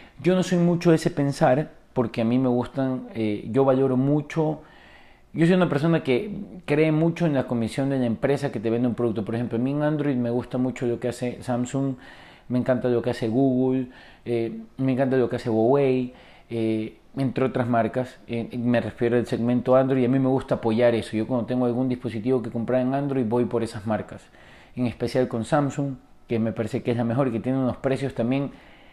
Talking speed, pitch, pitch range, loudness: 220 wpm, 125 Hz, 120-135 Hz, -24 LUFS